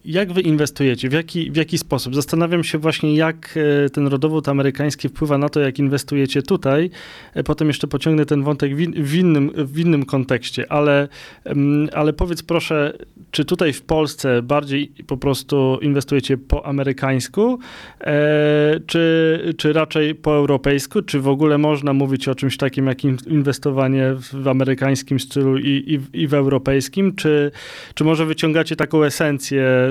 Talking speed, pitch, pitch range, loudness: 150 wpm, 145 Hz, 140-155 Hz, -18 LUFS